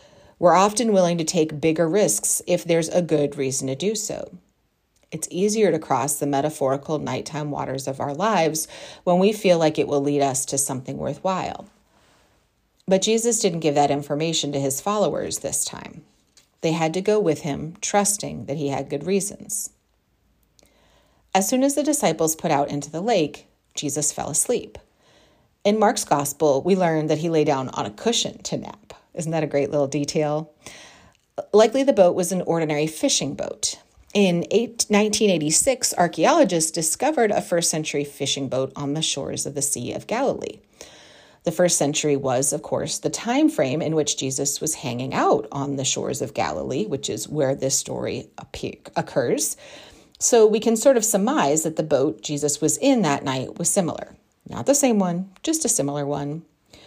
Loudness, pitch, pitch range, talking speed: -22 LUFS, 160 Hz, 145-195 Hz, 180 wpm